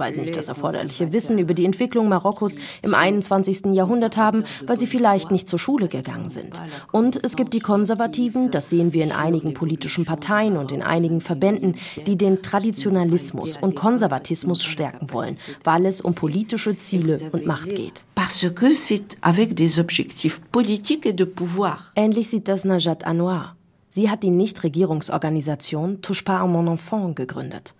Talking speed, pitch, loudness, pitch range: 145 wpm, 190 Hz, -21 LUFS, 165-210 Hz